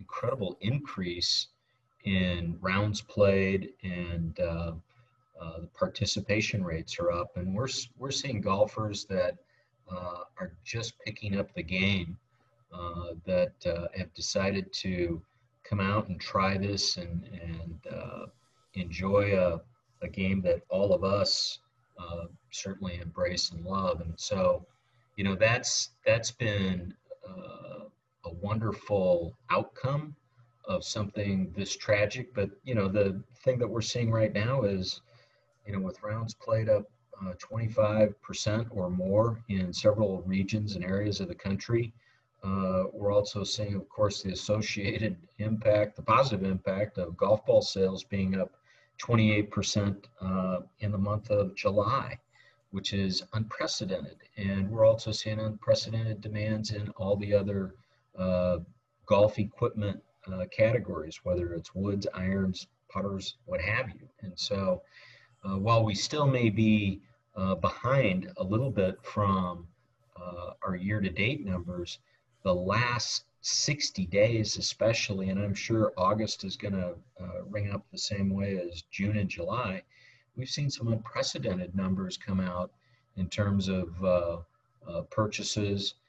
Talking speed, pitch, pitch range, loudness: 145 wpm, 100 Hz, 95-110 Hz, -30 LUFS